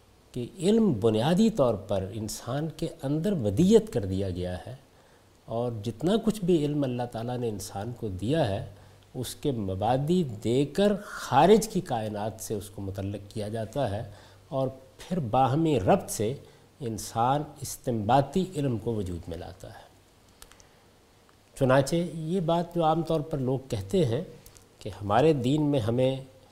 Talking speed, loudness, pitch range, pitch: 155 wpm, -27 LUFS, 105-155 Hz, 125 Hz